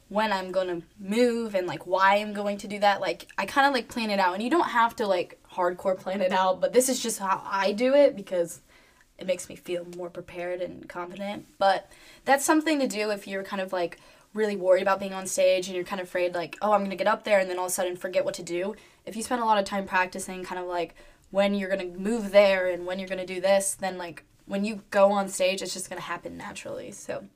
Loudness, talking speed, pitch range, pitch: -26 LUFS, 265 wpm, 185-210 Hz, 195 Hz